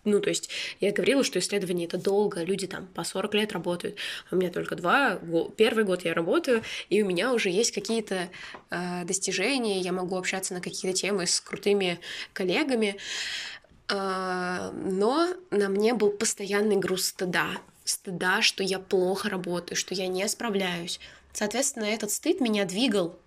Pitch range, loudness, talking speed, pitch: 185-210 Hz, -27 LUFS, 160 wpm, 195 Hz